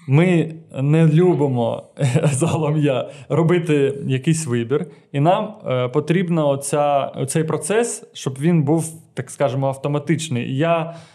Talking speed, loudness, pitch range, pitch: 95 wpm, -19 LUFS, 140-165 Hz, 150 Hz